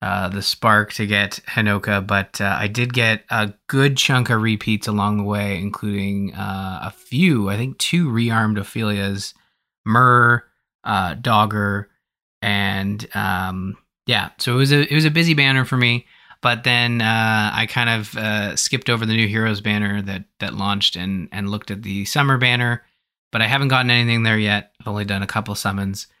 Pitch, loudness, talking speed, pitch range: 105 Hz, -19 LUFS, 185 wpm, 100-120 Hz